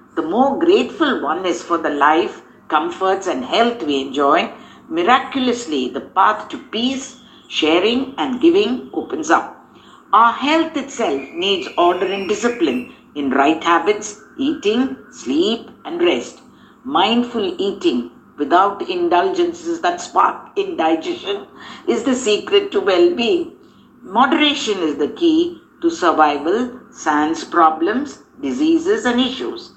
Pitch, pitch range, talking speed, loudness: 265 Hz, 210-345 Hz, 125 wpm, -18 LUFS